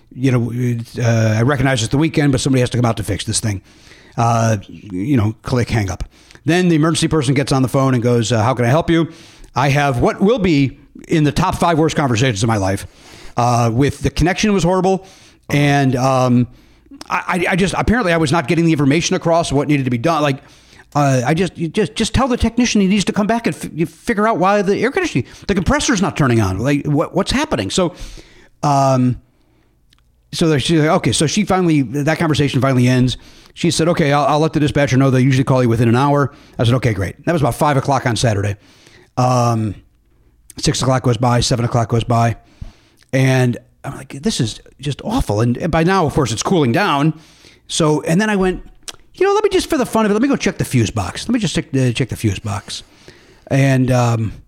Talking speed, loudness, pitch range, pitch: 230 wpm, -16 LUFS, 120-165 Hz, 140 Hz